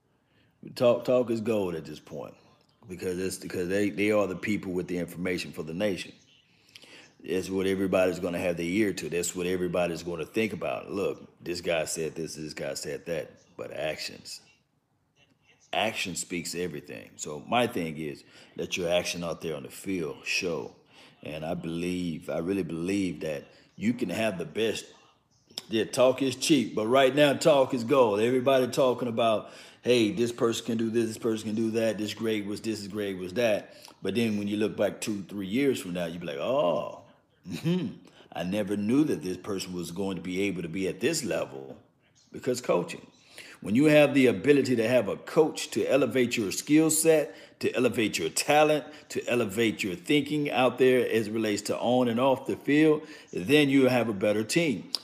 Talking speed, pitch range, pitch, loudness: 195 wpm, 90-125 Hz, 105 Hz, -28 LUFS